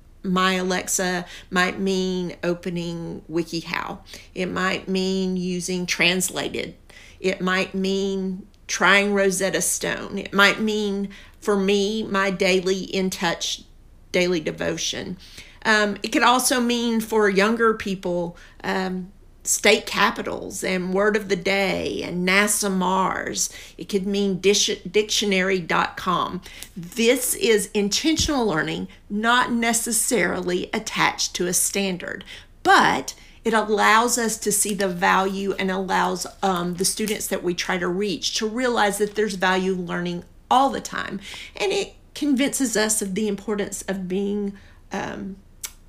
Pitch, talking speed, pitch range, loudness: 195 Hz, 130 wpm, 185-210 Hz, -22 LUFS